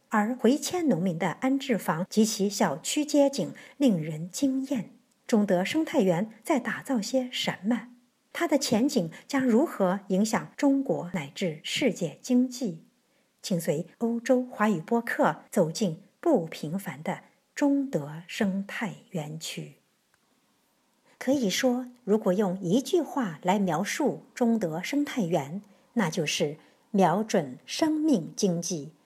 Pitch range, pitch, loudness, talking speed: 185-255 Hz, 220 Hz, -28 LUFS, 190 characters per minute